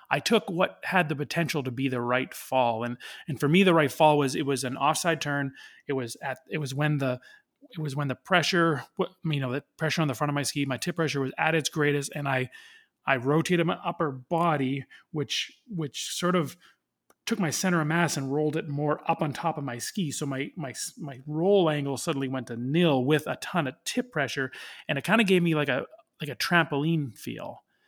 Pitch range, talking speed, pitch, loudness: 140-170 Hz, 230 wpm, 150 Hz, -27 LUFS